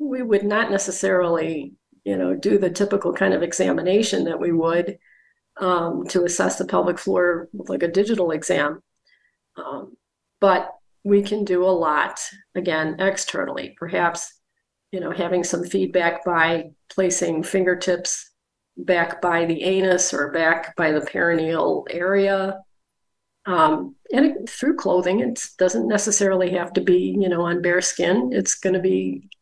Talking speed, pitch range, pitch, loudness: 150 wpm, 170-195 Hz, 180 Hz, -21 LUFS